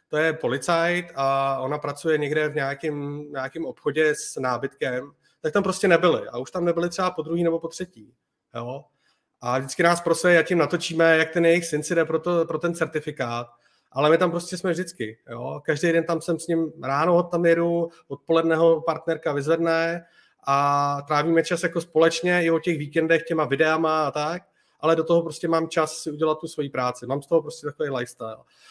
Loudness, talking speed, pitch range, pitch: -23 LUFS, 200 wpm, 145-170 Hz, 160 Hz